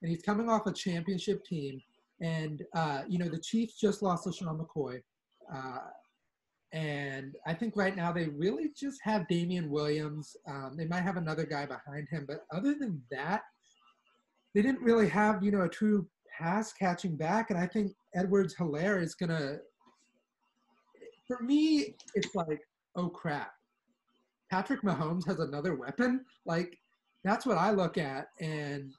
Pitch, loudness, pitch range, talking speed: 180 Hz, -33 LUFS, 155-210 Hz, 165 wpm